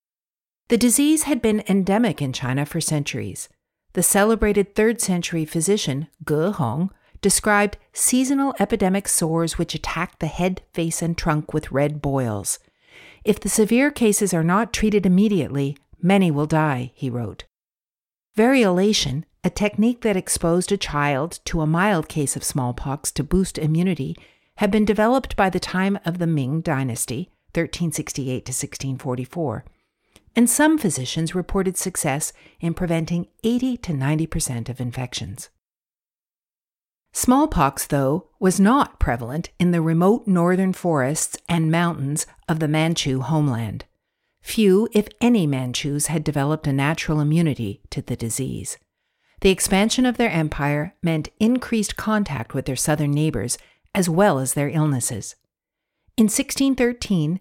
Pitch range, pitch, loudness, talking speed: 145-205 Hz, 165 Hz, -21 LUFS, 140 wpm